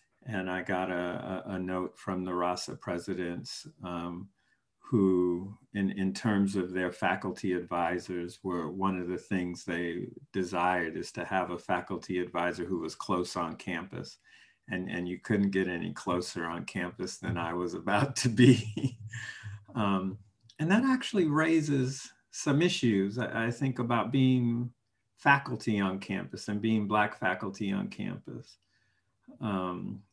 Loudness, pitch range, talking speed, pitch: -31 LUFS, 90-115 Hz, 145 wpm, 95 Hz